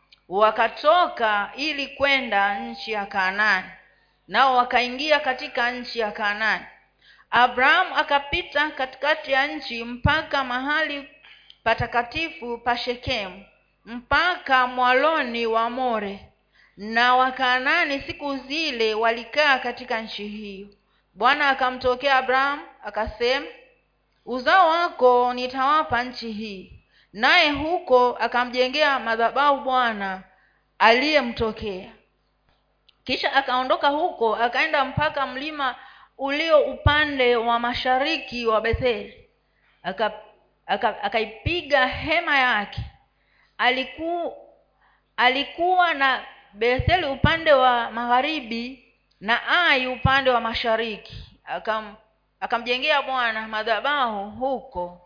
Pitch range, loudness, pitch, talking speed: 225-280 Hz, -22 LUFS, 250 Hz, 90 wpm